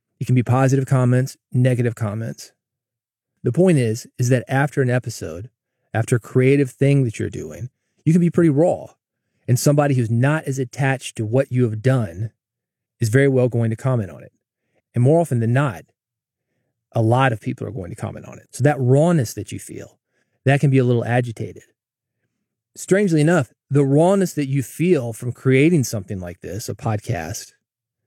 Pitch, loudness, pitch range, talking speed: 125 Hz, -19 LUFS, 115-140 Hz, 185 wpm